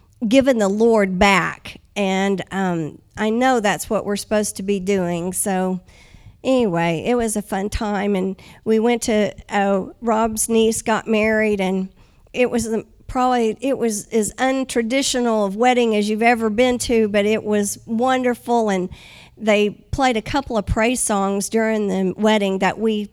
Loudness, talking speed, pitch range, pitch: -19 LUFS, 165 wpm, 200-235 Hz, 215 Hz